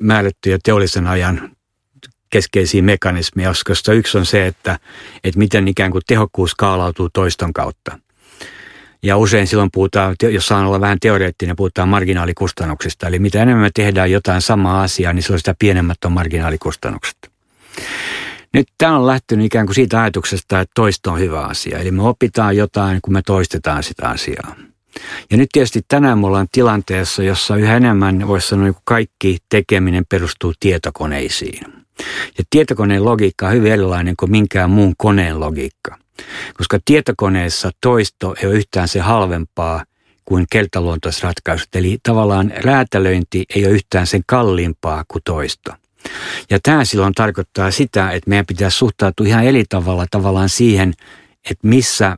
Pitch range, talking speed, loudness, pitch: 90-105 Hz, 150 wpm, -15 LUFS, 95 Hz